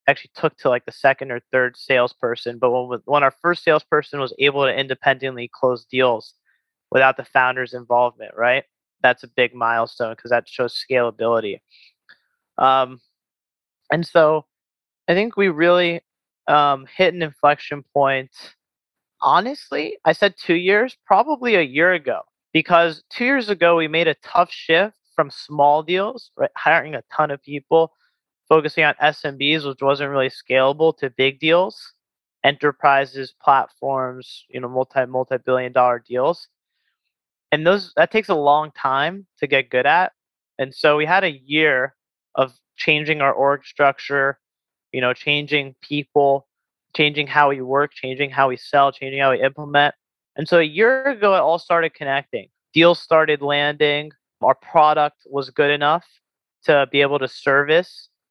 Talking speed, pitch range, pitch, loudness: 155 wpm, 130-160 Hz, 145 Hz, -19 LUFS